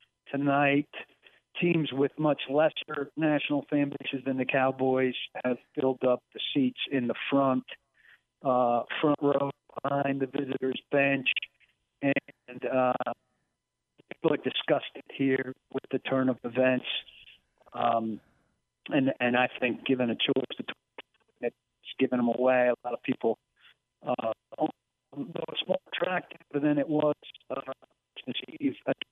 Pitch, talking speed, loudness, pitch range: 135 Hz, 135 wpm, -29 LUFS, 125-145 Hz